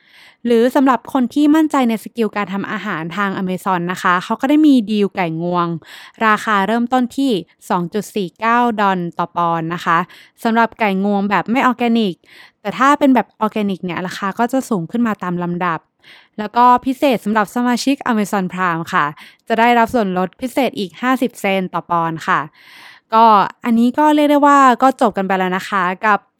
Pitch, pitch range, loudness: 215 Hz, 185-245 Hz, -16 LUFS